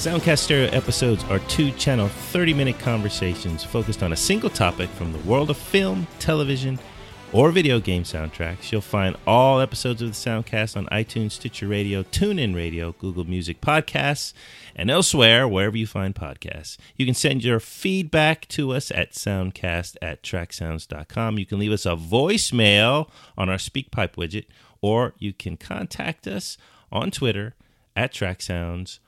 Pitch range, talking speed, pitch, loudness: 95-130 Hz, 155 wpm, 110 Hz, -22 LUFS